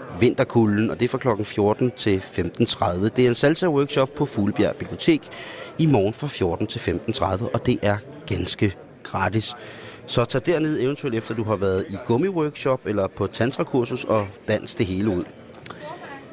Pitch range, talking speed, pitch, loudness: 105-130 Hz, 170 wpm, 115 Hz, -23 LUFS